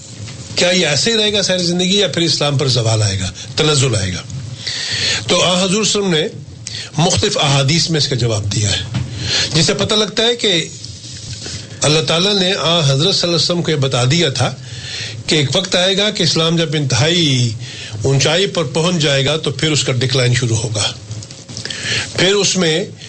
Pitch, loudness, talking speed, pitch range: 140 Hz, -14 LUFS, 185 wpm, 115-170 Hz